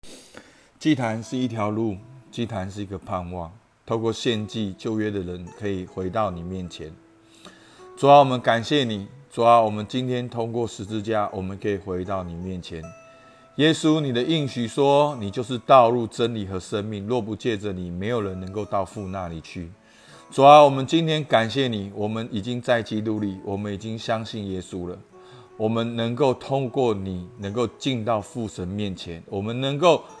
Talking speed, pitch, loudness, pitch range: 260 characters per minute, 110 Hz, -23 LUFS, 100-125 Hz